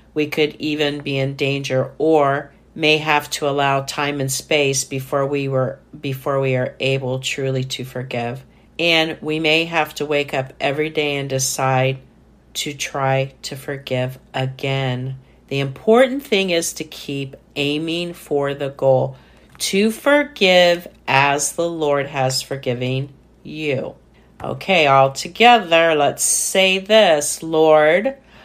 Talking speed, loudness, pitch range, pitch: 135 wpm, -18 LUFS, 135-155 Hz, 140 Hz